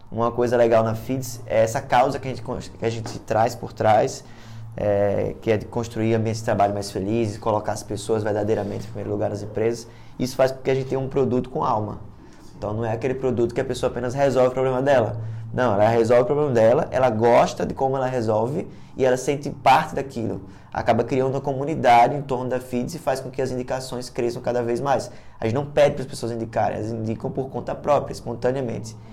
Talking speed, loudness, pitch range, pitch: 225 wpm, -22 LUFS, 110-130 Hz, 120 Hz